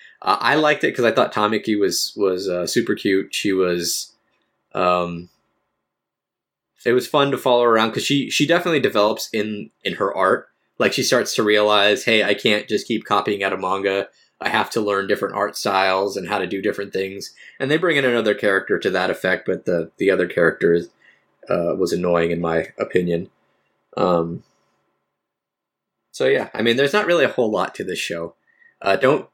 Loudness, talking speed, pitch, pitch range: -19 LUFS, 190 wpm, 105 Hz, 90-120 Hz